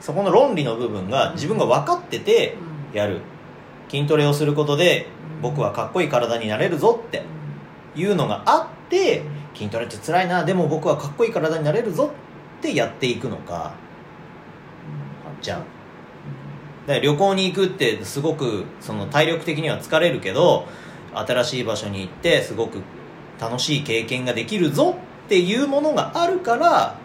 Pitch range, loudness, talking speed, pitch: 115-180 Hz, -21 LUFS, 315 characters per minute, 150 Hz